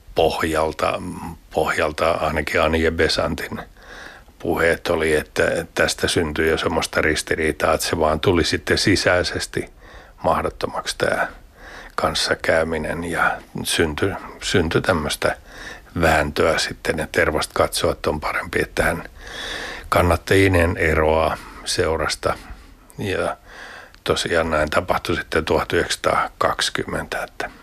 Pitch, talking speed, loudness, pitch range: 80 Hz, 100 wpm, -20 LUFS, 80-85 Hz